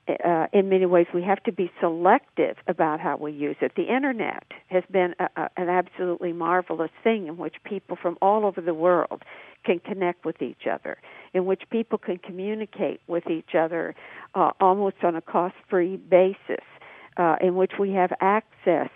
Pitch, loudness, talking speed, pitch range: 180 Hz, -25 LUFS, 185 wpm, 170-195 Hz